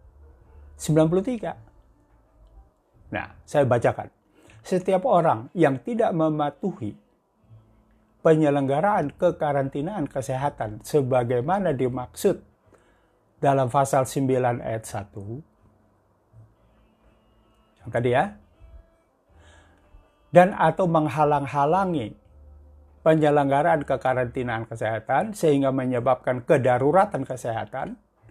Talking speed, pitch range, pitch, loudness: 65 wpm, 110-155 Hz, 130 Hz, -23 LUFS